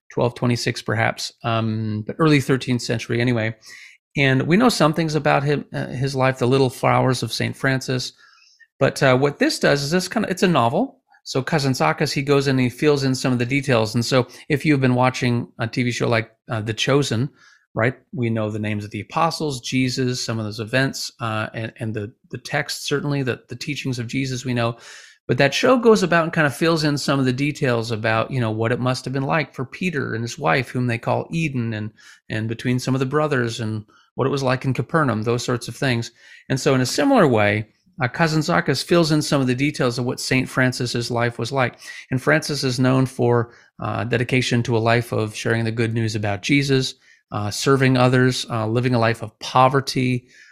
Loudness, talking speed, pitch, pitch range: -21 LUFS, 225 wpm, 130 Hz, 115-140 Hz